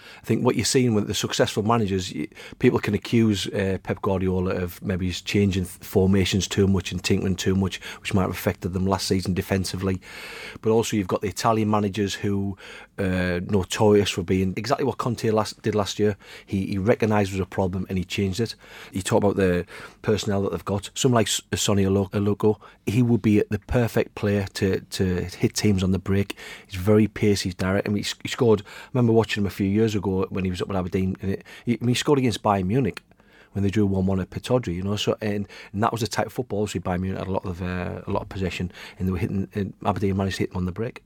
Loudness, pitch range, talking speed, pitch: -24 LUFS, 95-110 Hz, 240 wpm, 100 Hz